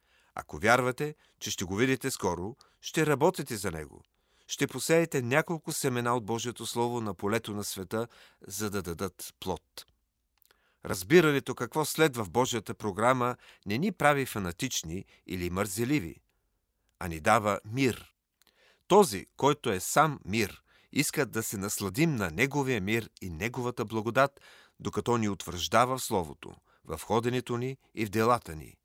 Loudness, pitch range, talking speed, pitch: -29 LUFS, 100-130 Hz, 145 wpm, 120 Hz